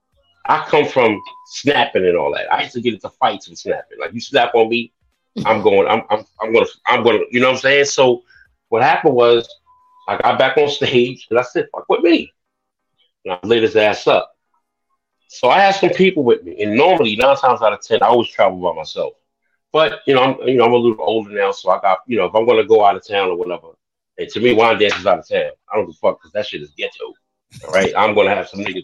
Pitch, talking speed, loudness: 190 Hz, 255 wpm, -15 LUFS